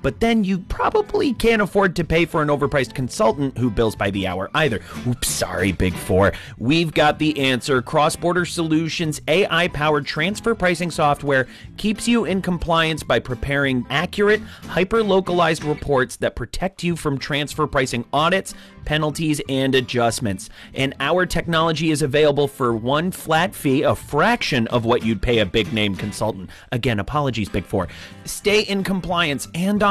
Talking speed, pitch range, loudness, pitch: 165 wpm, 120-175 Hz, -20 LUFS, 150 Hz